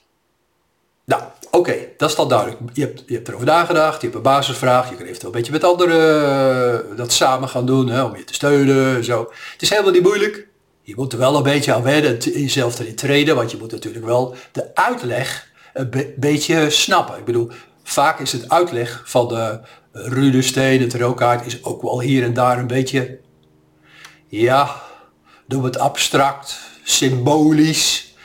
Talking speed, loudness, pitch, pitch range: 185 wpm, -17 LUFS, 130 Hz, 120-145 Hz